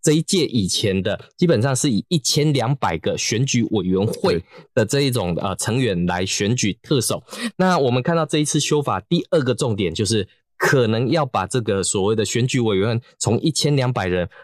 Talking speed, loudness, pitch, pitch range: 285 characters per minute, -20 LUFS, 125 Hz, 110-150 Hz